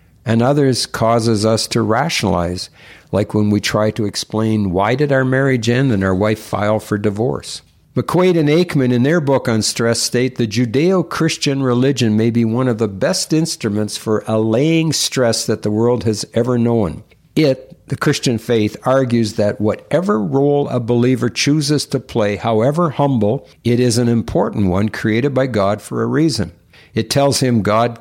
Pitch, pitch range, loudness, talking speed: 120 Hz, 110-135 Hz, -16 LUFS, 175 wpm